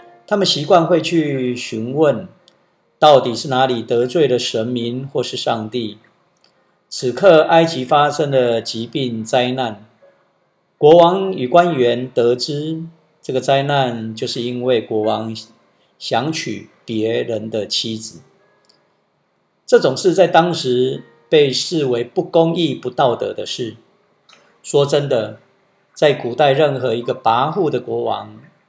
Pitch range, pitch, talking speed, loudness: 120-165 Hz, 130 Hz, 185 characters per minute, -16 LUFS